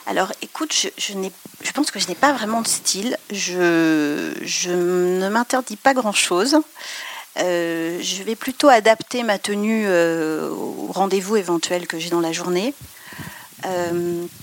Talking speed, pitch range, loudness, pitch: 155 wpm, 175-240 Hz, -20 LUFS, 195 Hz